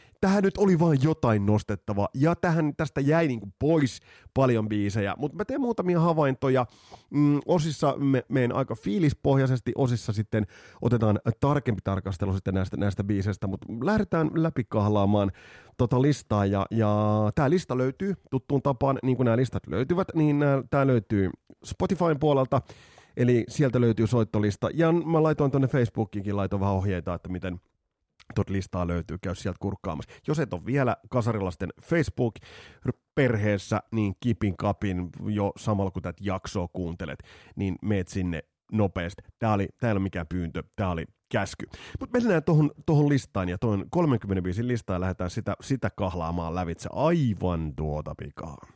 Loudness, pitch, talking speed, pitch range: -27 LUFS, 115 Hz, 150 wpm, 100-140 Hz